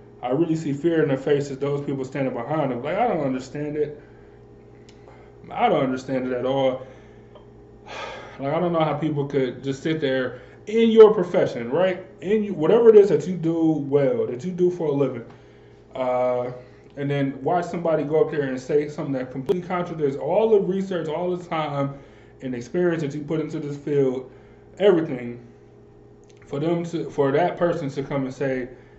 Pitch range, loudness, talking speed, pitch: 130-165 Hz, -23 LUFS, 190 wpm, 145 Hz